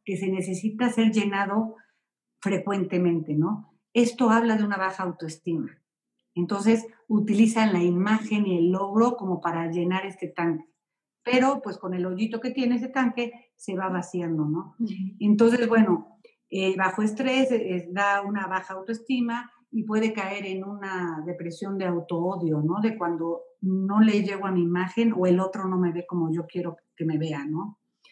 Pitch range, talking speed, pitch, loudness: 175-225 Hz, 170 wpm, 195 Hz, -26 LUFS